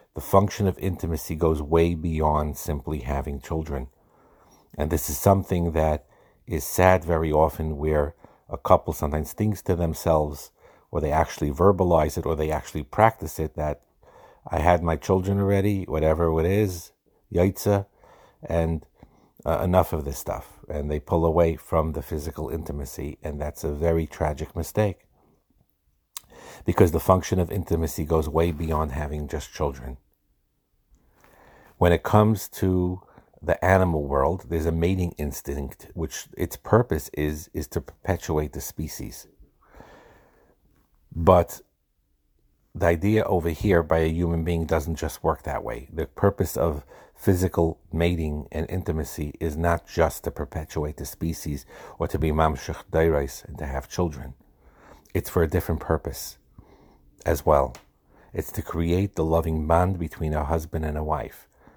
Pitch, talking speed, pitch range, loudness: 80 Hz, 150 wpm, 75-90 Hz, -25 LUFS